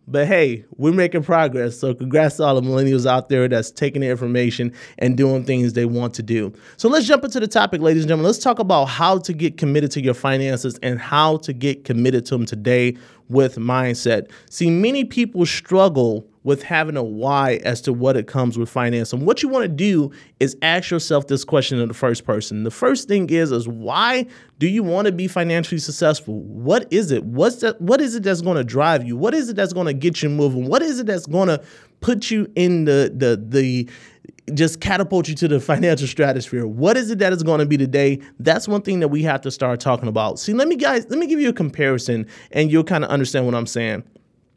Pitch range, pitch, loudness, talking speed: 125-180 Hz, 145 Hz, -19 LUFS, 230 wpm